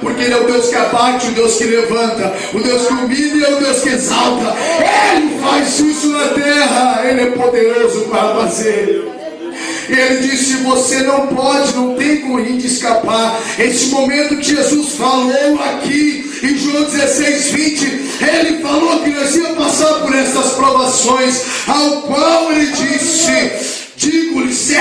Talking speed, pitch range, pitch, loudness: 155 wpm, 250-295 Hz, 270 Hz, -12 LUFS